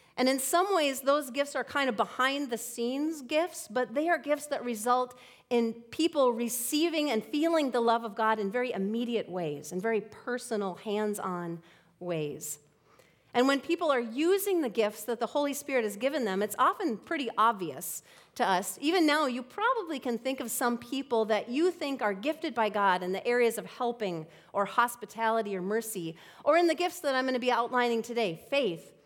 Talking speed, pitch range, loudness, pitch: 195 wpm, 215-285 Hz, -30 LUFS, 245 Hz